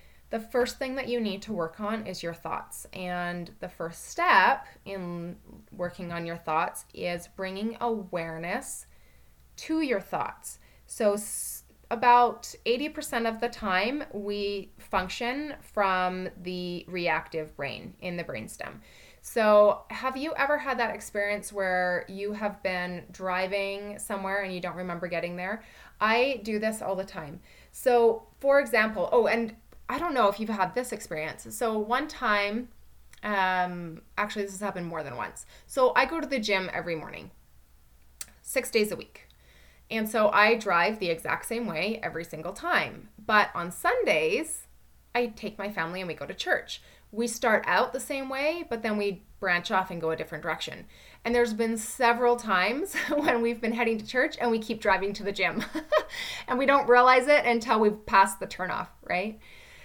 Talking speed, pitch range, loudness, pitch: 170 wpm, 180-235 Hz, -28 LUFS, 205 Hz